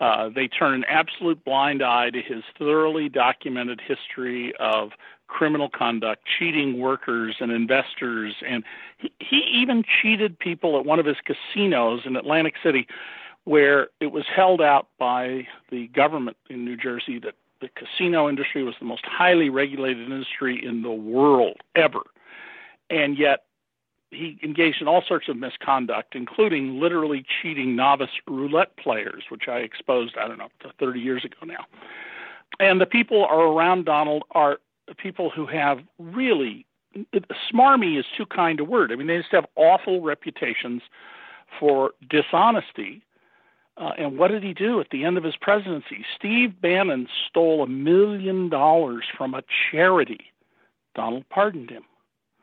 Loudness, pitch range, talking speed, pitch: -22 LUFS, 125-180 Hz, 150 wpm, 150 Hz